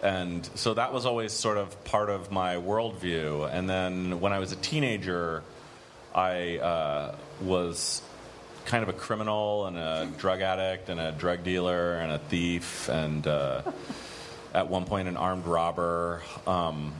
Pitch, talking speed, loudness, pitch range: 90 Hz, 160 wpm, -30 LUFS, 85-100 Hz